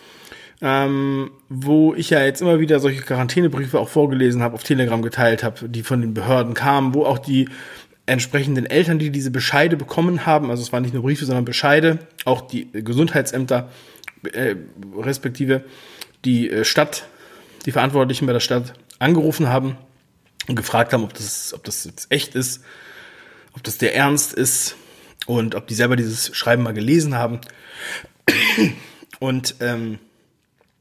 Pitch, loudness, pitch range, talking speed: 130 Hz, -19 LUFS, 120-140 Hz, 155 wpm